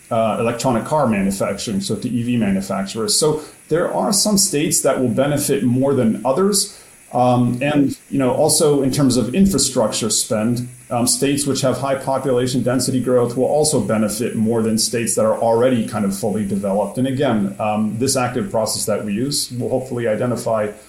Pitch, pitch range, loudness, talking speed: 125 Hz, 115-145 Hz, -18 LUFS, 180 wpm